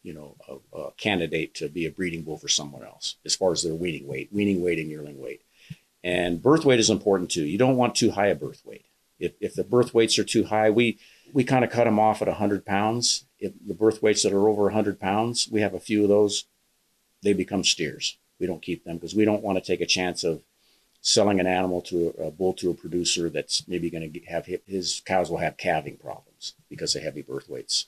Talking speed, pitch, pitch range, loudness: 245 wpm, 100 Hz, 90-110 Hz, -24 LUFS